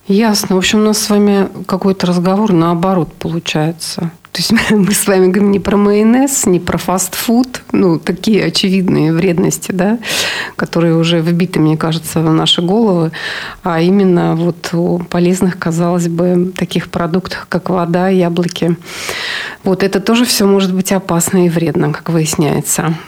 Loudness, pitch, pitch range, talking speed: -13 LUFS, 185 Hz, 170-195 Hz, 155 wpm